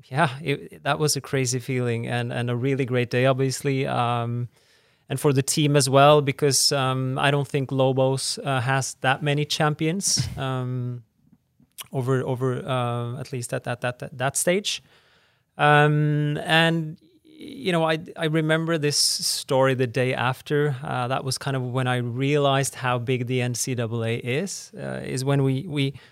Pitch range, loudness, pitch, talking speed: 125-150 Hz, -23 LUFS, 135 Hz, 170 wpm